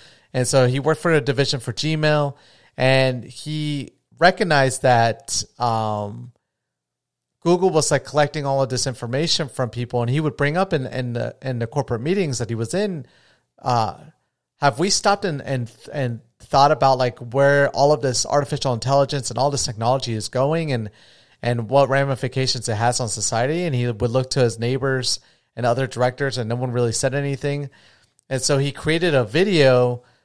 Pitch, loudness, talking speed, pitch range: 130 Hz, -20 LUFS, 185 wpm, 120-145 Hz